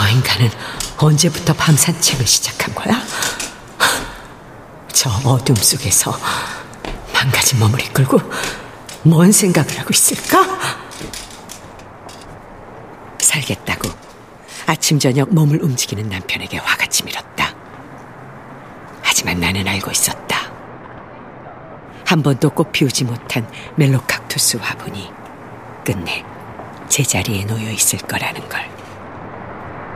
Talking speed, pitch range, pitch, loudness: 210 characters per minute, 115-160 Hz, 135 Hz, -16 LUFS